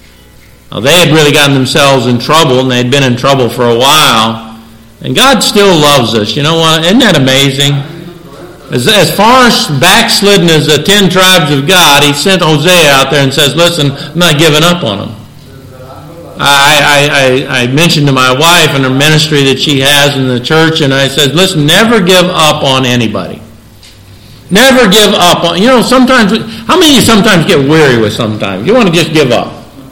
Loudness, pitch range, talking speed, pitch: -5 LUFS, 130-175 Hz, 200 wpm, 145 Hz